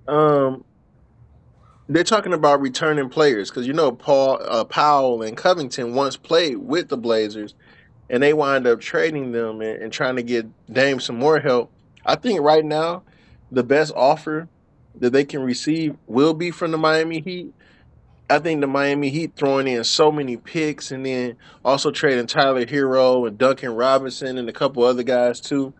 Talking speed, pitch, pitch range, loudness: 175 wpm, 135 Hz, 125-155 Hz, -20 LUFS